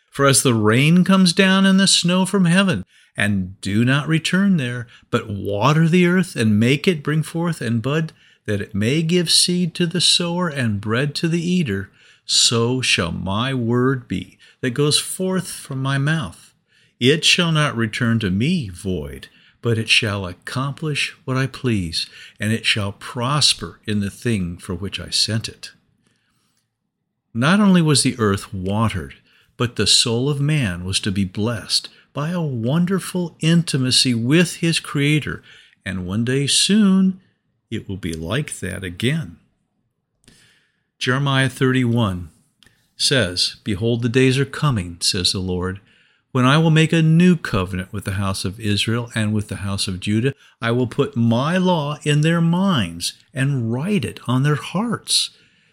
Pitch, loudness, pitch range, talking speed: 125 Hz, -19 LUFS, 105-160 Hz, 165 wpm